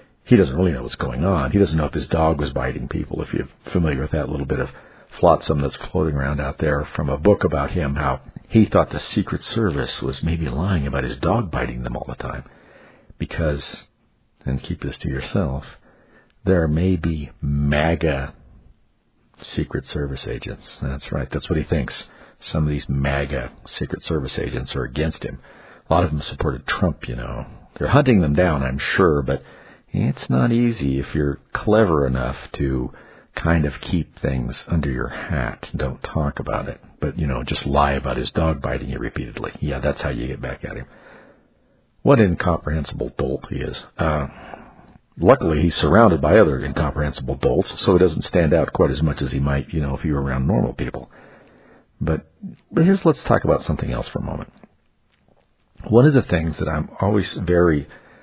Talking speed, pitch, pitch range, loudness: 190 wpm, 75 Hz, 70-85 Hz, -21 LUFS